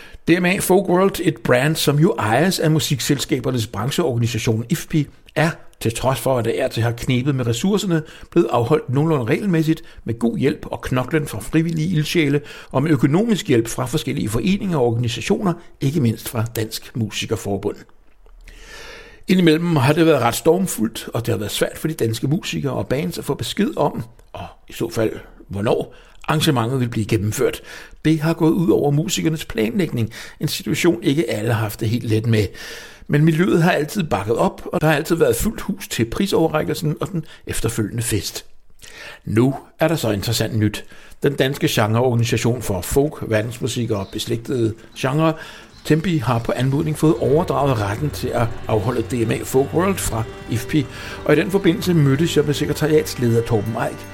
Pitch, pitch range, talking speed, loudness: 145 Hz, 115-160 Hz, 175 wpm, -20 LUFS